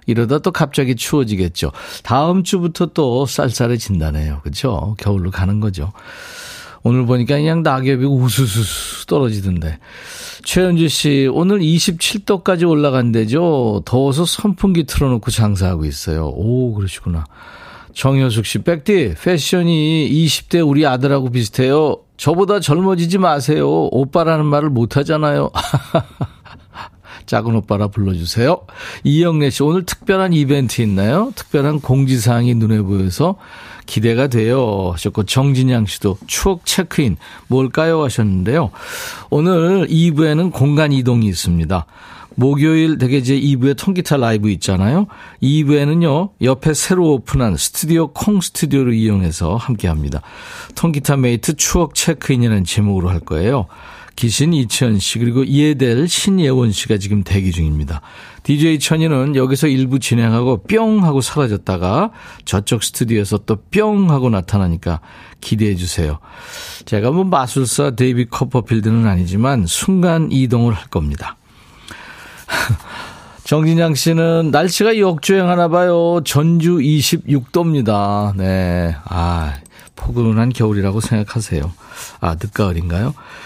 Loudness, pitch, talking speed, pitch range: -15 LUFS, 130 Hz, 300 characters per minute, 105-160 Hz